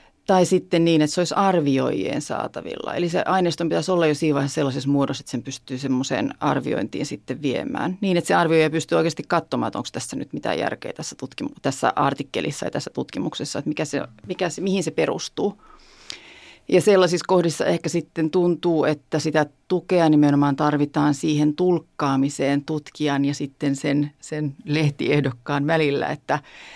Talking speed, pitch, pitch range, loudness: 165 wpm, 155 Hz, 145-170 Hz, -22 LUFS